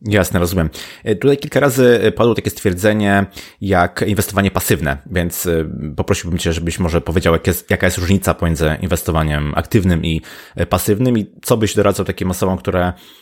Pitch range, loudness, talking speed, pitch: 85-105 Hz, -16 LUFS, 155 wpm, 95 Hz